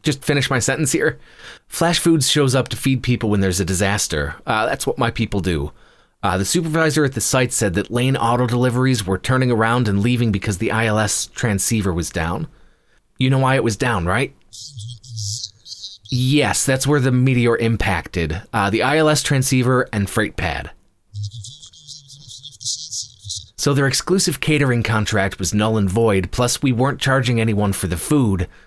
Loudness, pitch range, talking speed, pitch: -18 LUFS, 105-135 Hz, 170 wpm, 115 Hz